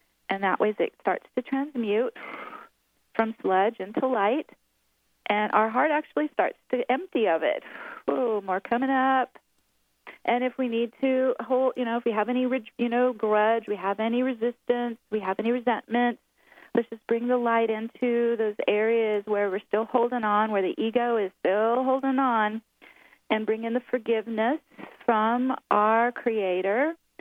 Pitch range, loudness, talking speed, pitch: 215-250 Hz, -26 LUFS, 165 wpm, 235 Hz